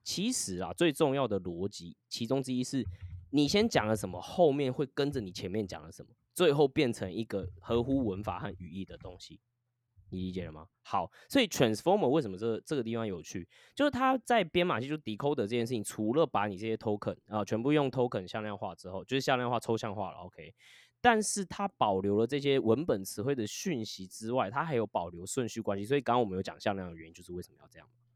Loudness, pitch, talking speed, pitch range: -32 LUFS, 115 Hz, 385 characters per minute, 95-140 Hz